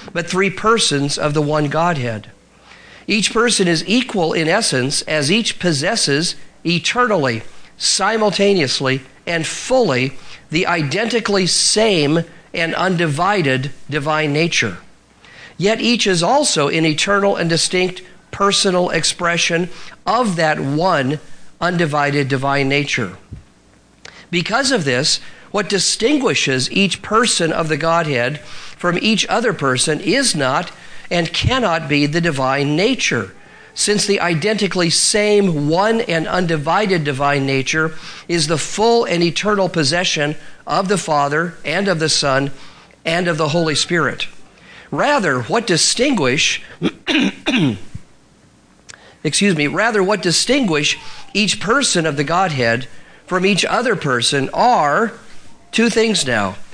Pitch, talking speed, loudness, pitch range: 170 Hz, 120 wpm, -16 LUFS, 150-195 Hz